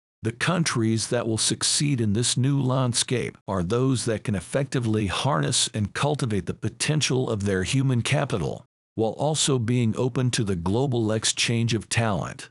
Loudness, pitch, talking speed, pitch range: -24 LUFS, 120 Hz, 160 wpm, 110-135 Hz